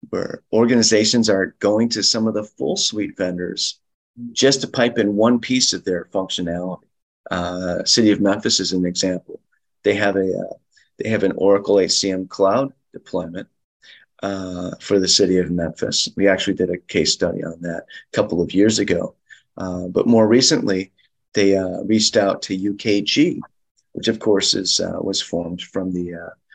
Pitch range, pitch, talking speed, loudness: 90-110 Hz, 100 Hz, 175 wpm, -19 LUFS